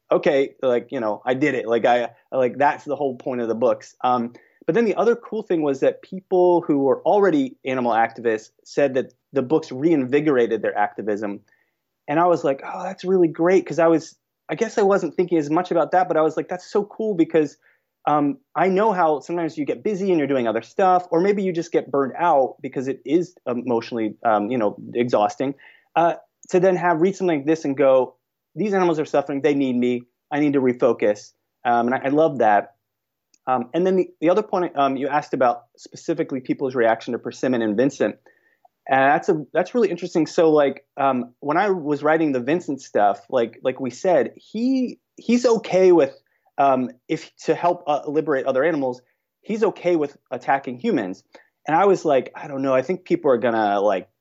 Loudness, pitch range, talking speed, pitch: -21 LUFS, 130-180 Hz, 210 wpm, 150 Hz